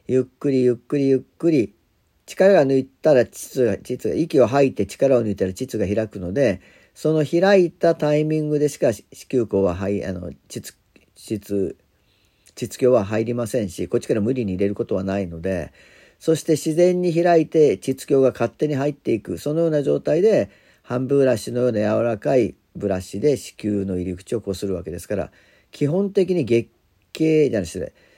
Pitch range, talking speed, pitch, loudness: 100-150 Hz, 345 characters per minute, 120 Hz, -21 LUFS